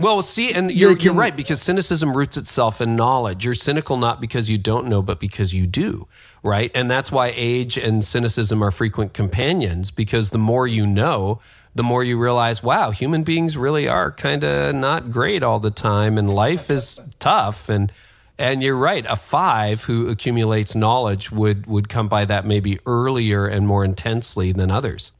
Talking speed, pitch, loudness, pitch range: 190 wpm, 115 Hz, -19 LUFS, 105-130 Hz